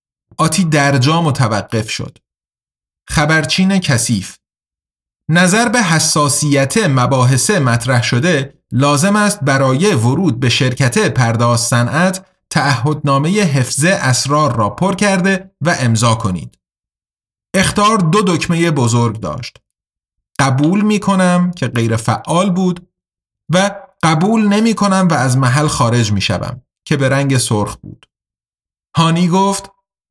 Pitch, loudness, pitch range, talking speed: 145 Hz, -13 LUFS, 125-185 Hz, 115 wpm